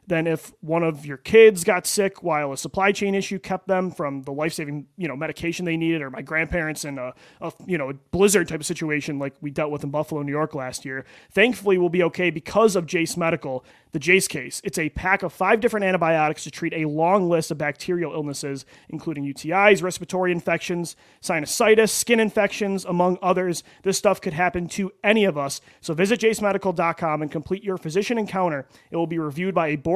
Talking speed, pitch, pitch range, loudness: 210 wpm, 170 Hz, 155-190 Hz, -22 LUFS